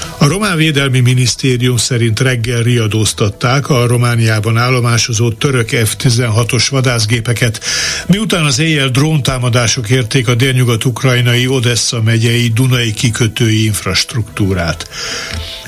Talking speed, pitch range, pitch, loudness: 95 wpm, 115-130 Hz, 120 Hz, -12 LUFS